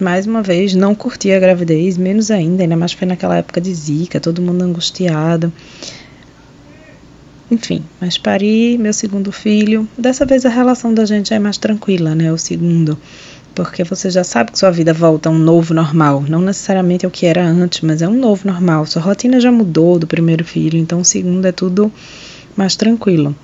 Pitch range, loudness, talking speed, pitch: 165-205 Hz, -13 LUFS, 190 wpm, 180 Hz